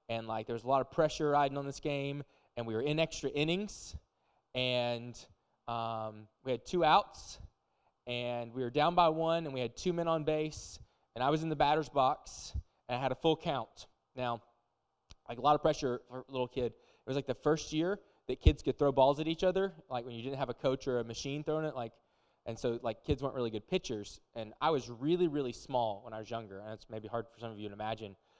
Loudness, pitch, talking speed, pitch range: -34 LUFS, 125 Hz, 245 wpm, 115-150 Hz